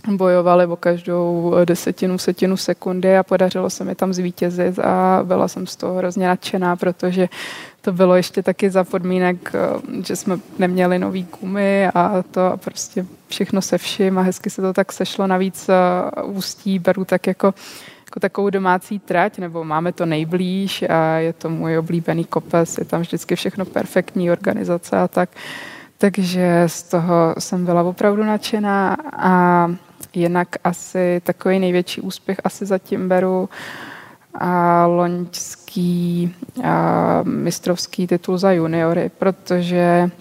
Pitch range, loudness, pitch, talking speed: 175-190 Hz, -18 LUFS, 180 Hz, 140 wpm